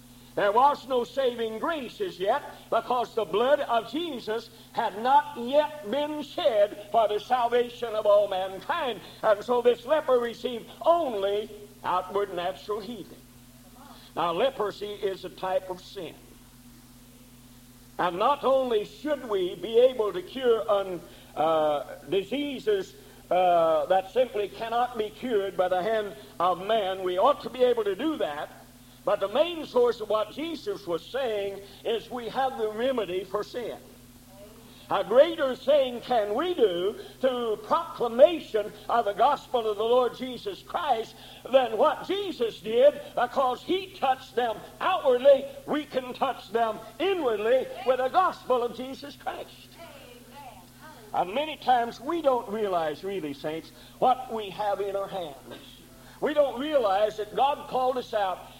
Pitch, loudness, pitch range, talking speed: 235 Hz, -27 LUFS, 200-280 Hz, 145 wpm